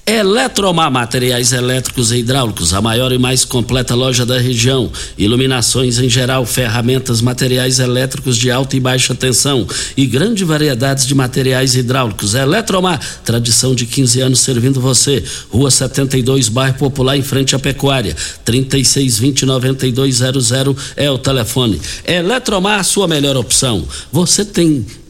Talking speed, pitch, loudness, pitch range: 135 wpm, 130 Hz, -13 LUFS, 125-135 Hz